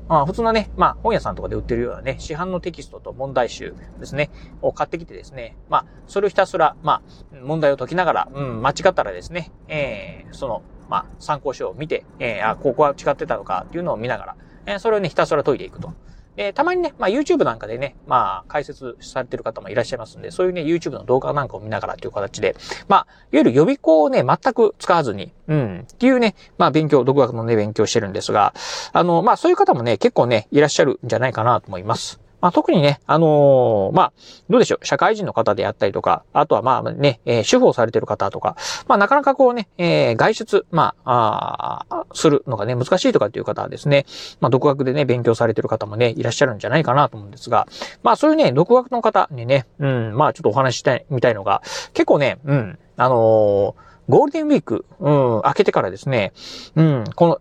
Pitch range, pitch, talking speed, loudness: 135-225 Hz, 155 Hz, 465 characters per minute, -19 LUFS